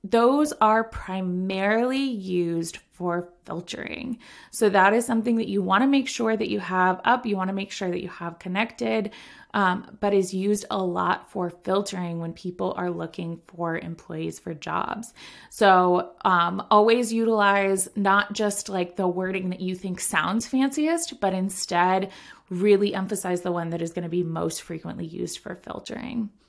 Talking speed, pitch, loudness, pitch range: 165 wpm, 195 Hz, -24 LUFS, 180-225 Hz